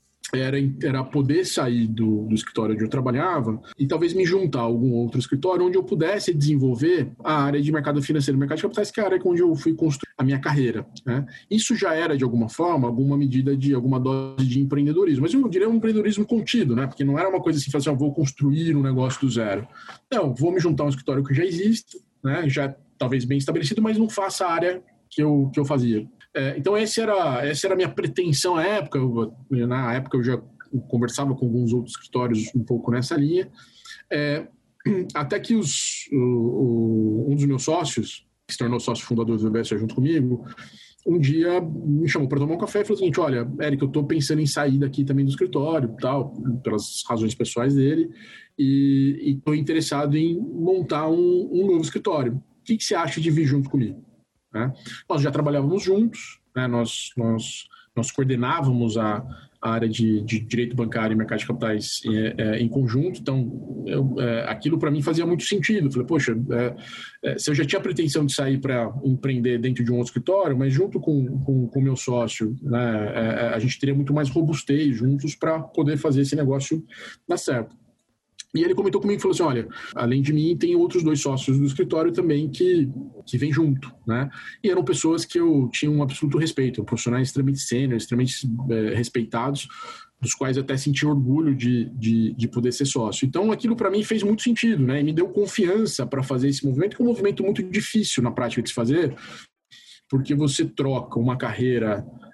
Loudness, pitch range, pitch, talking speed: -23 LUFS, 125-165 Hz, 140 Hz, 205 wpm